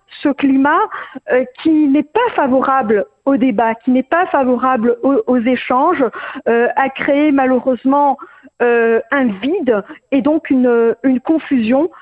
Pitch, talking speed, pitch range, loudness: 270 Hz, 135 wpm, 250-290 Hz, -14 LUFS